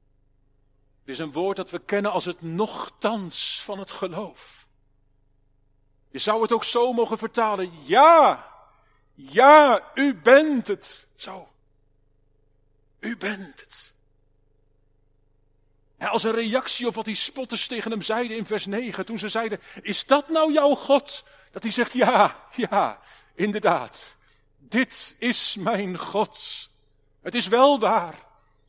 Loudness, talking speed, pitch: -22 LUFS, 135 wpm, 200 Hz